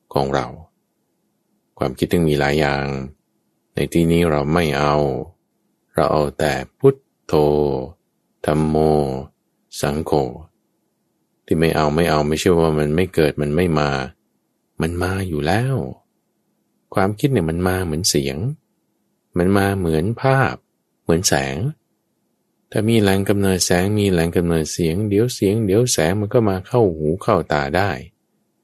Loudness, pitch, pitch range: -19 LUFS, 85 Hz, 75-100 Hz